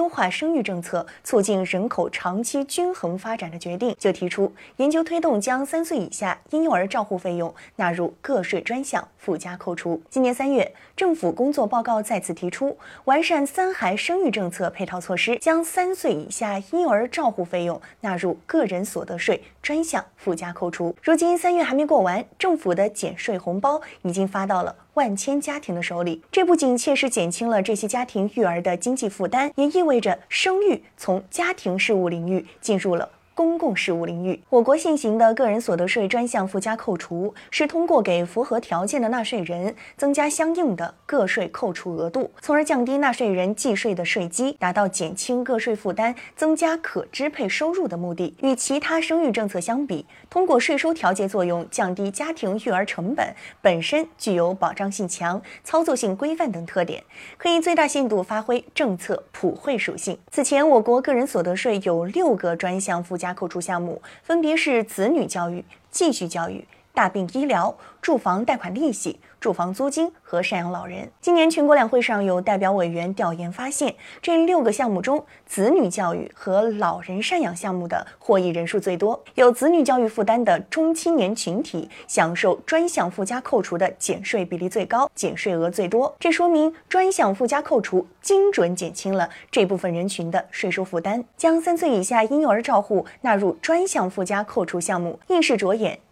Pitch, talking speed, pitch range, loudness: 225 Hz, 290 characters per minute, 180-295 Hz, -22 LUFS